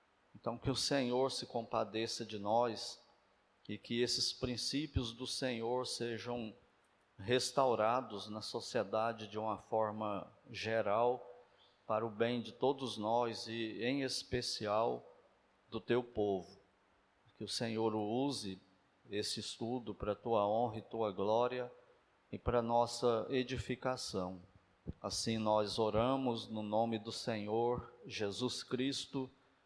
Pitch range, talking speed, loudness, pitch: 105-125 Hz, 125 wpm, -38 LUFS, 115 Hz